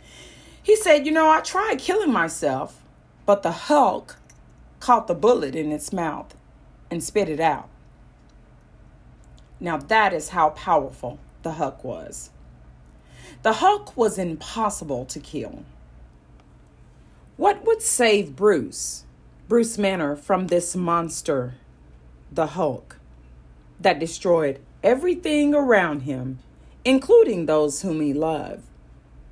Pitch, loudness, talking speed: 165 Hz, -22 LUFS, 115 wpm